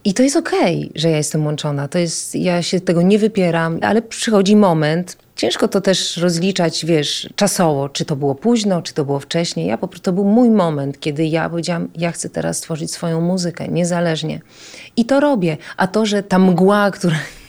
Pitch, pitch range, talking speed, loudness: 175 Hz, 160-200 Hz, 200 wpm, -17 LUFS